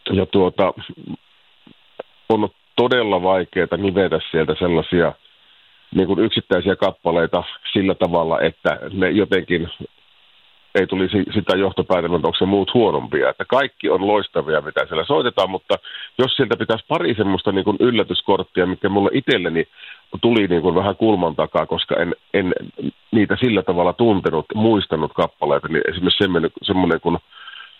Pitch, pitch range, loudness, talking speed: 95 Hz, 90-110 Hz, -19 LUFS, 130 wpm